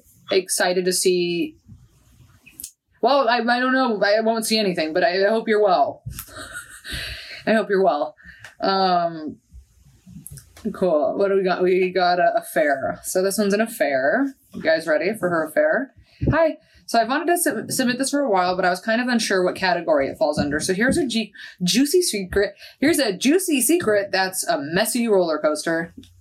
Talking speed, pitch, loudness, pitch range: 185 wpm, 215 Hz, -20 LUFS, 185-280 Hz